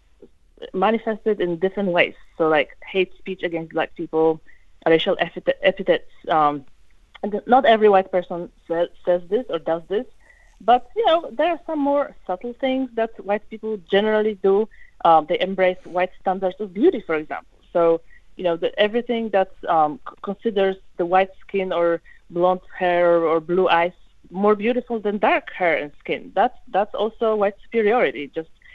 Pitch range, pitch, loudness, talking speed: 175-225 Hz, 190 Hz, -21 LUFS, 165 wpm